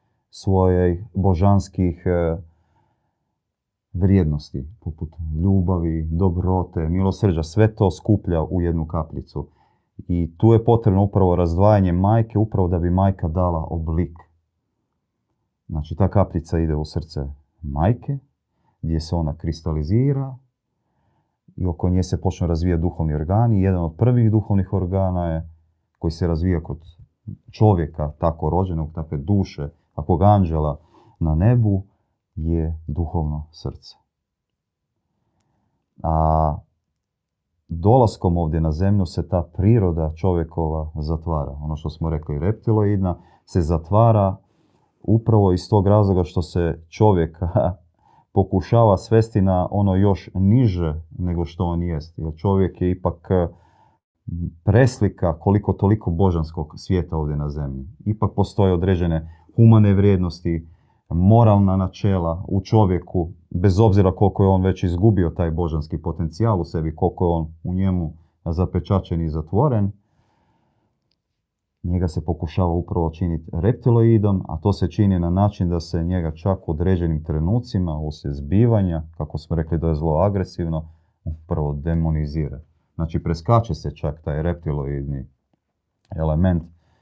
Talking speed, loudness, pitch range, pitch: 125 wpm, -21 LUFS, 80-100 Hz, 90 Hz